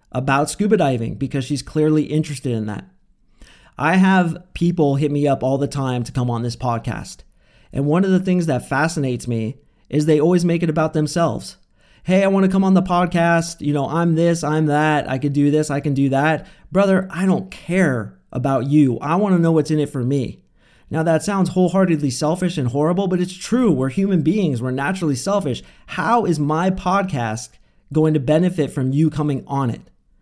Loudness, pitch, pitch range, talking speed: -19 LUFS, 155 Hz, 140-180 Hz, 200 wpm